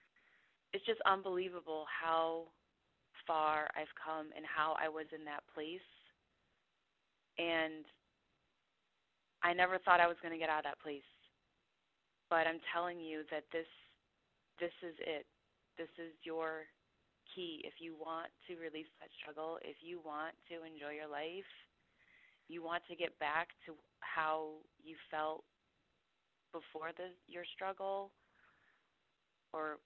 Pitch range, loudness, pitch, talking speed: 155-175 Hz, -40 LUFS, 165 Hz, 135 wpm